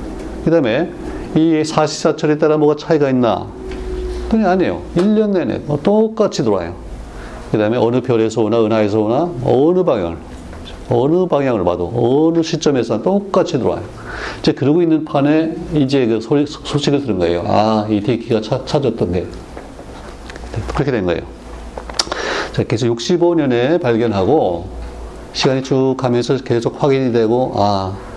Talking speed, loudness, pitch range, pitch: 295 characters per minute, -16 LUFS, 105-155 Hz, 125 Hz